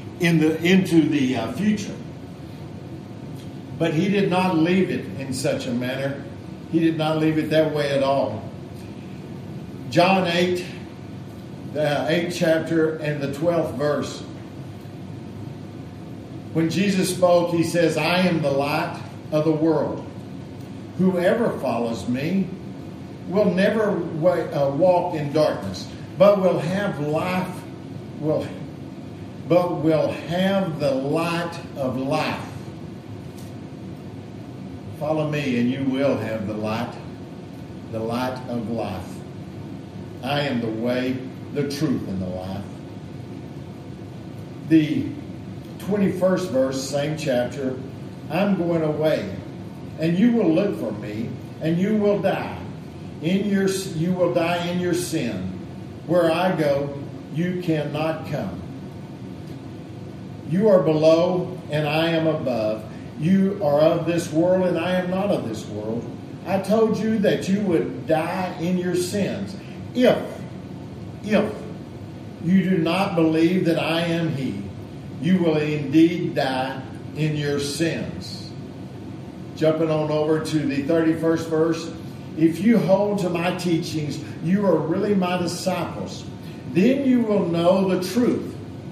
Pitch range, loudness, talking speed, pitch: 140-180 Hz, -22 LUFS, 130 wpm, 160 Hz